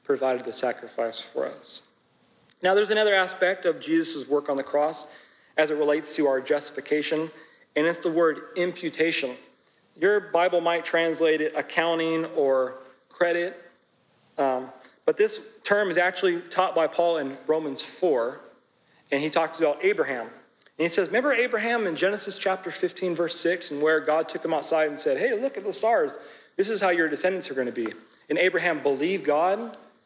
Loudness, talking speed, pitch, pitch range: -25 LUFS, 175 wpm, 170 Hz, 150-190 Hz